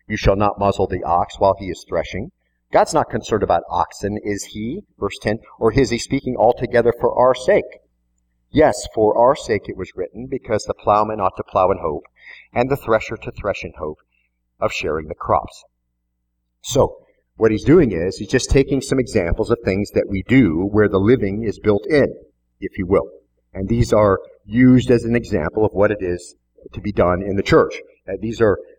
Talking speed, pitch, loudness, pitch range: 200 wpm, 105 Hz, -18 LUFS, 95-120 Hz